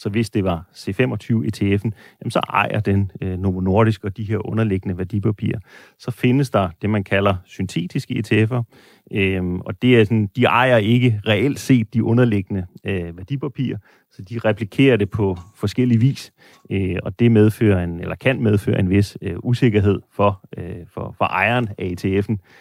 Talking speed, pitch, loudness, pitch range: 170 wpm, 105 Hz, -19 LUFS, 95-120 Hz